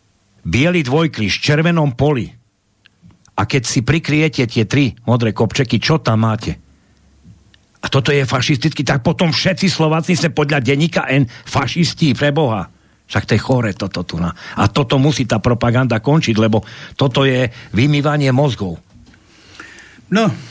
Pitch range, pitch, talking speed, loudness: 110-150 Hz, 130 Hz, 140 wpm, -16 LUFS